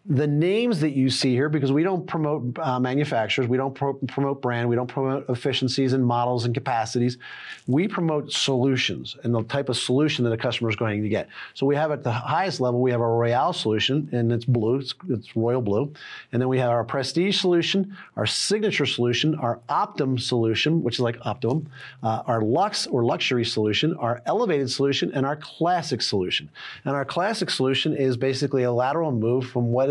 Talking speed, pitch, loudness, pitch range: 200 wpm, 130 Hz, -24 LUFS, 120-145 Hz